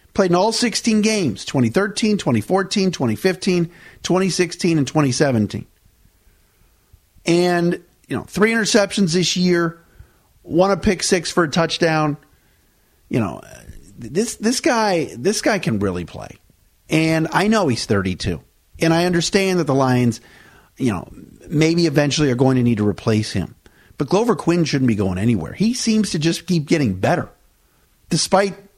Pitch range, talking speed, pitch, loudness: 120-190 Hz, 150 wpm, 165 Hz, -18 LUFS